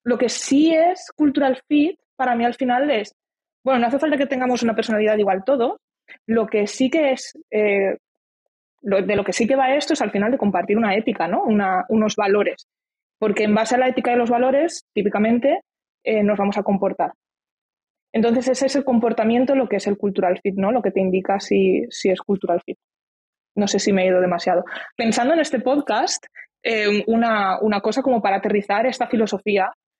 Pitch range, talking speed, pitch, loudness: 205-260 Hz, 205 wpm, 225 Hz, -20 LUFS